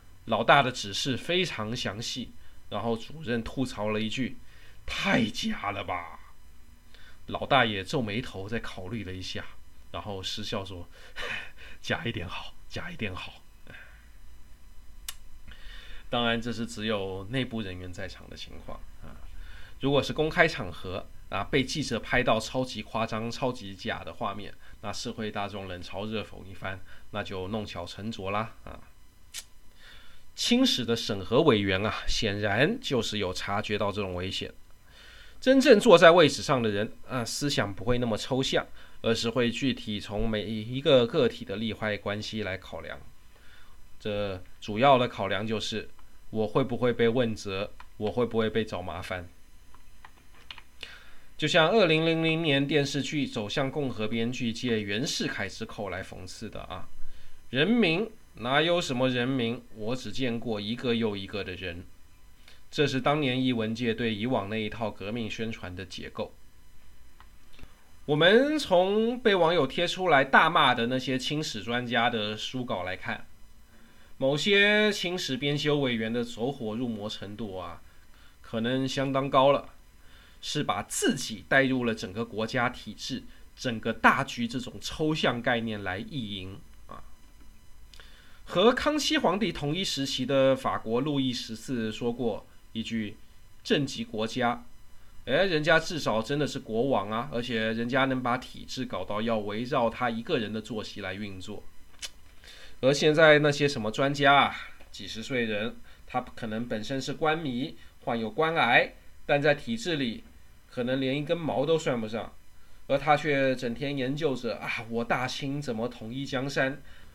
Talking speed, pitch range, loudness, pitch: 225 characters per minute, 100-135 Hz, -28 LUFS, 115 Hz